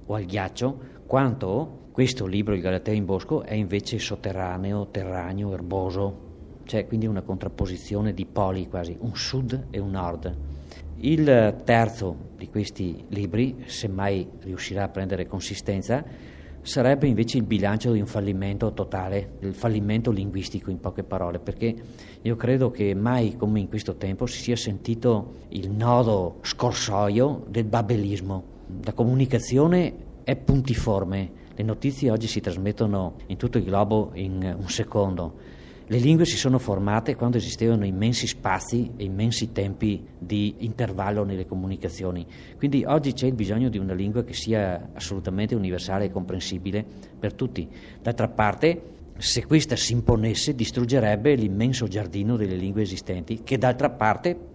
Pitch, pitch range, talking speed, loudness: 105 Hz, 95-120 Hz, 145 wpm, -25 LUFS